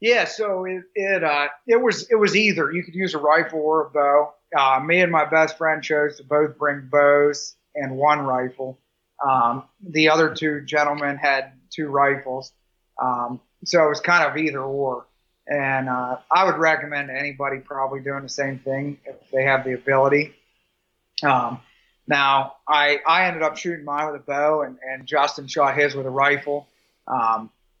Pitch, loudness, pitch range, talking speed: 145 Hz, -21 LUFS, 135-155 Hz, 180 wpm